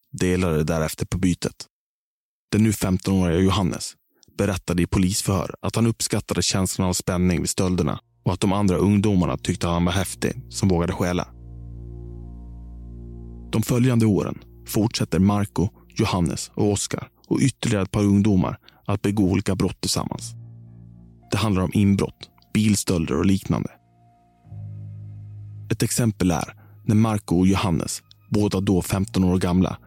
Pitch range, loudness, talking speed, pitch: 90-105 Hz, -22 LUFS, 140 wpm, 95 Hz